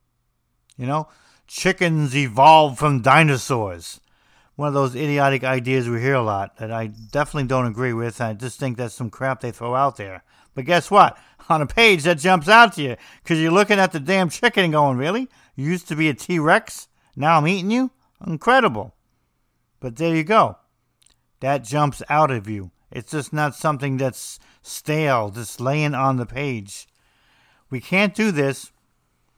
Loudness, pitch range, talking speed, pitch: -19 LUFS, 125-160 Hz, 180 wpm, 140 Hz